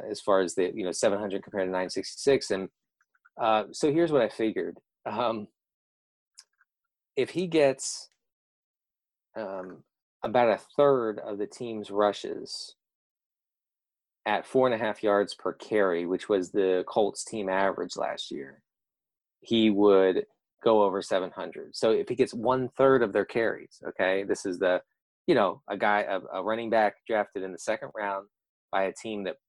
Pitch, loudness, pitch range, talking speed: 105 Hz, -28 LUFS, 95-130 Hz, 165 wpm